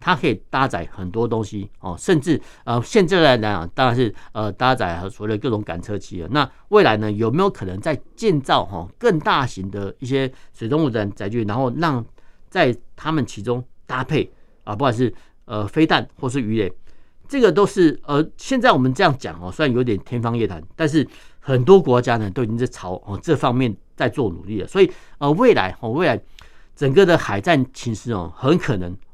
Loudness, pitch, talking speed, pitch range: -20 LUFS, 120 Hz, 290 characters per minute, 105-145 Hz